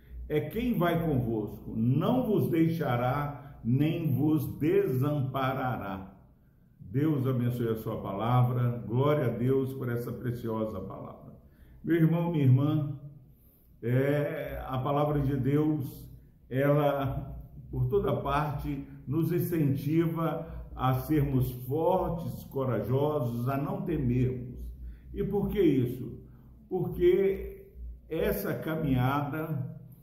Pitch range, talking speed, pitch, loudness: 125-155 Hz, 100 wpm, 140 Hz, -29 LUFS